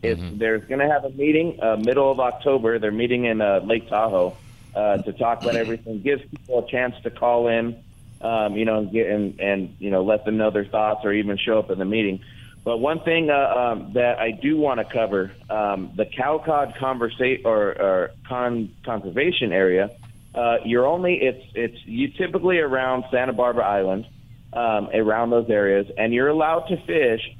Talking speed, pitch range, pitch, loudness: 195 wpm, 110-130 Hz, 115 Hz, -22 LUFS